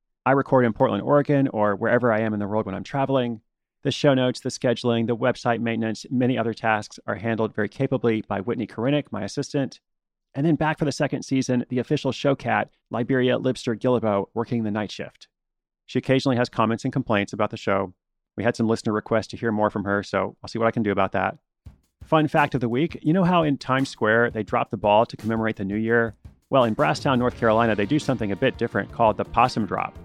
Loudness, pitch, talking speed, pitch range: -23 LUFS, 120 Hz, 230 wpm, 110-130 Hz